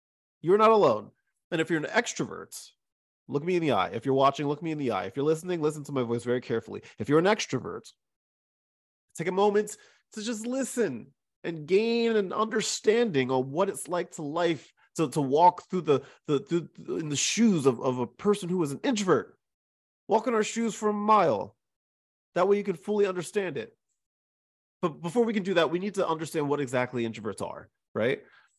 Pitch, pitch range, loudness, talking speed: 170 Hz, 145-210 Hz, -27 LUFS, 205 wpm